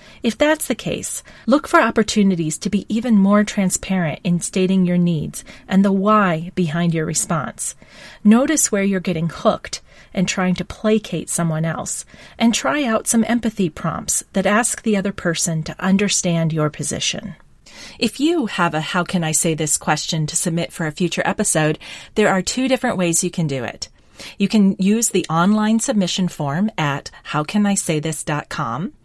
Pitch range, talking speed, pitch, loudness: 165-215 Hz, 170 wpm, 190 Hz, -19 LUFS